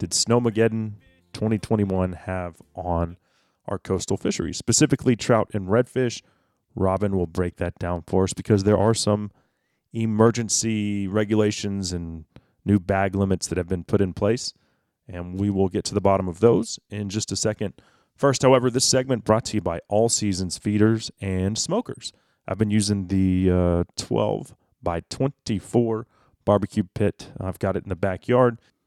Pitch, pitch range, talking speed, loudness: 105 Hz, 95-115 Hz, 160 wpm, -23 LUFS